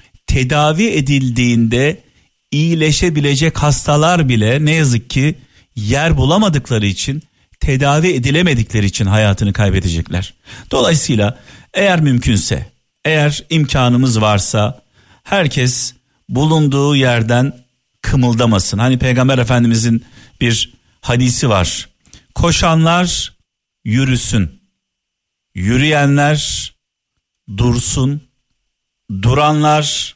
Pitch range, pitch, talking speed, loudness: 110-145 Hz, 125 Hz, 75 wpm, -14 LUFS